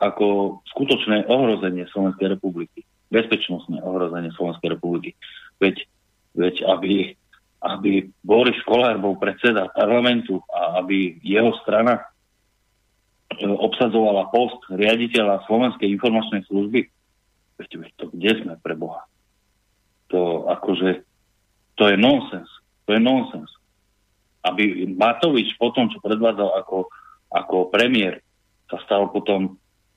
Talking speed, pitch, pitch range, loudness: 110 wpm, 100 Hz, 95-110 Hz, -20 LUFS